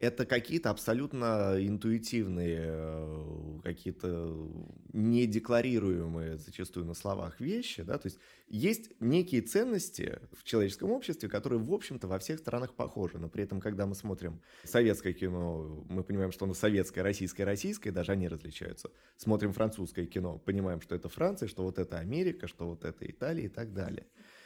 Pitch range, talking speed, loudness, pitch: 85-115 Hz, 150 wpm, -34 LUFS, 95 Hz